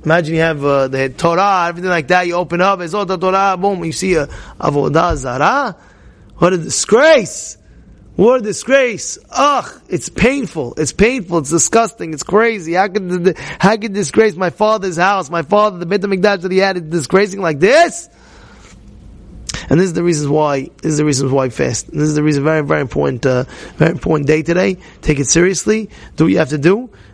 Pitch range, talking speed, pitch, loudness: 155-200 Hz, 200 wpm, 175 Hz, -14 LUFS